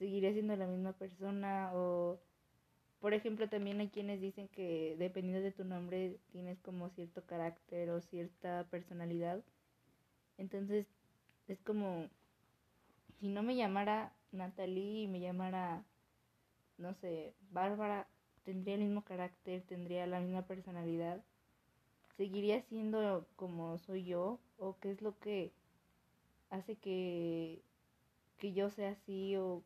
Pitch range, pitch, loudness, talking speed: 180-200 Hz, 190 Hz, -42 LUFS, 125 wpm